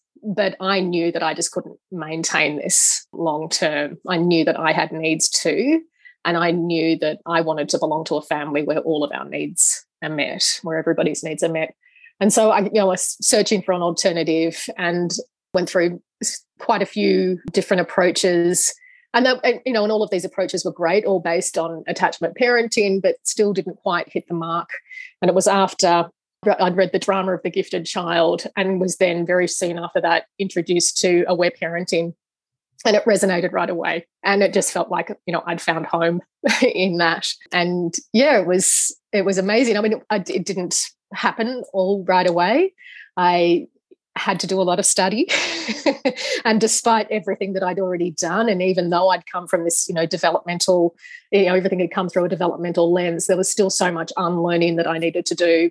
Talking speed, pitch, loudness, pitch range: 200 wpm, 185 Hz, -19 LUFS, 170-200 Hz